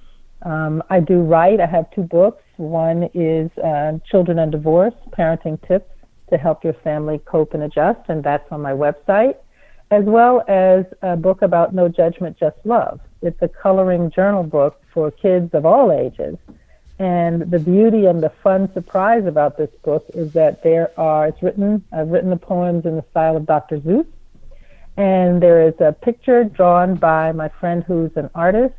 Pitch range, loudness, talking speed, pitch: 160-190 Hz, -17 LUFS, 180 wpm, 170 Hz